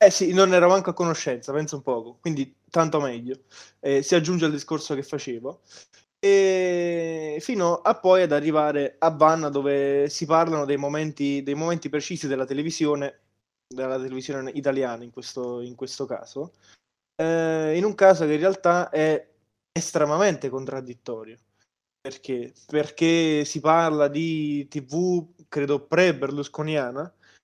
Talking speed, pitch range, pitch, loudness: 140 wpm, 135-165 Hz, 150 Hz, -23 LUFS